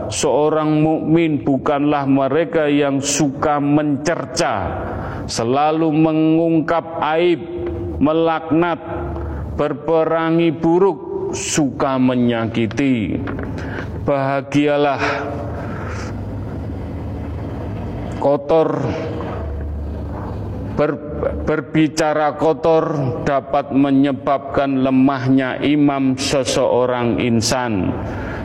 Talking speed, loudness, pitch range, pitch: 55 wpm, -18 LUFS, 110-155 Hz, 140 Hz